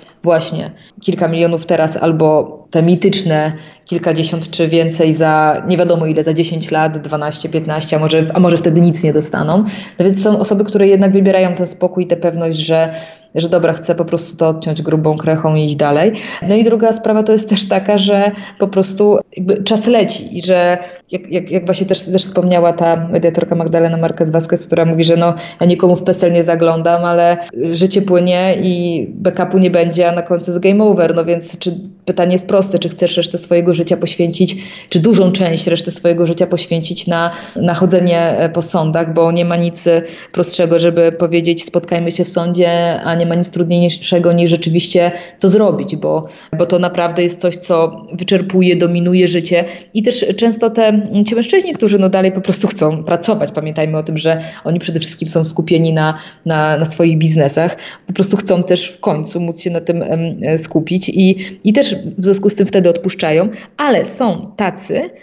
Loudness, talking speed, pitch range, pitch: -13 LUFS, 190 wpm, 165-185 Hz, 175 Hz